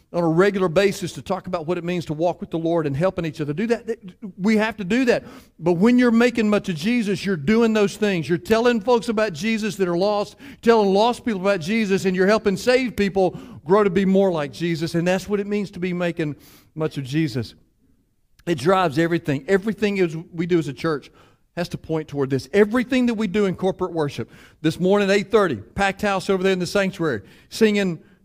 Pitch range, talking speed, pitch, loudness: 170-210 Hz, 225 wpm, 190 Hz, -21 LUFS